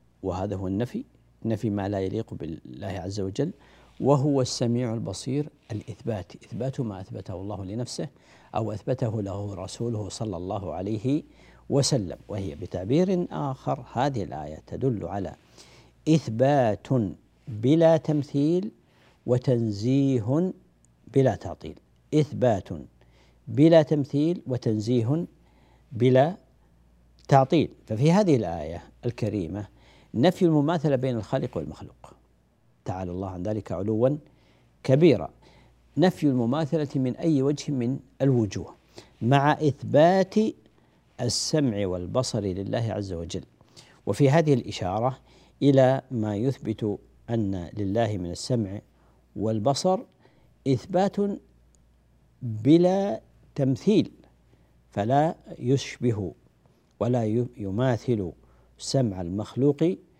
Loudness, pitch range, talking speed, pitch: -26 LUFS, 95-140 Hz, 95 wpm, 120 Hz